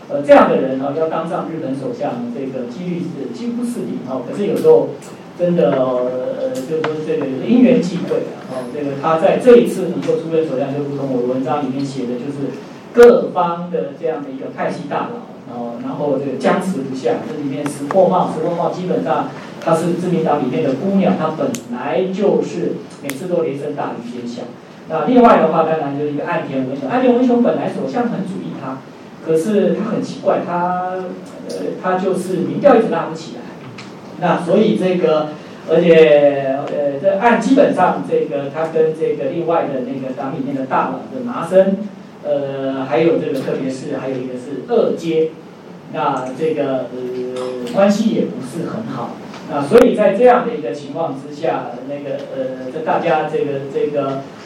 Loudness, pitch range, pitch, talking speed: -17 LUFS, 145-205 Hz, 165 Hz, 280 characters per minute